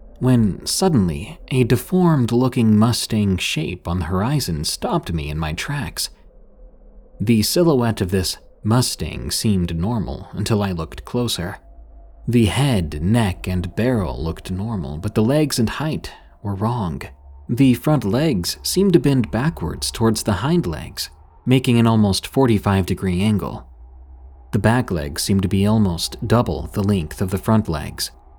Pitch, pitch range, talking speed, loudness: 100 Hz, 85-120 Hz, 150 wpm, -20 LUFS